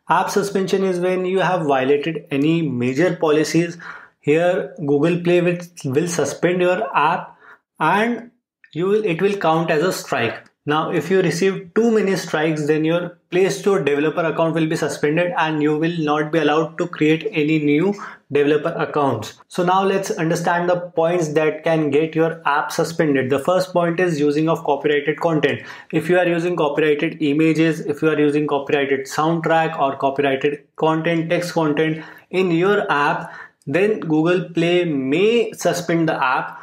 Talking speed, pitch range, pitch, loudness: 165 wpm, 150-180 Hz, 165 Hz, -19 LUFS